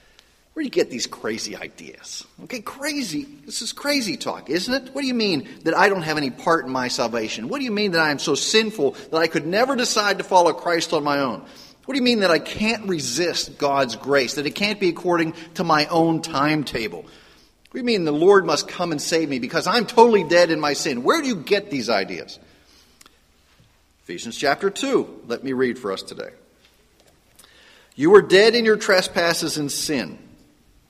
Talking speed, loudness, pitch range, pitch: 210 wpm, -20 LUFS, 150-230 Hz, 180 Hz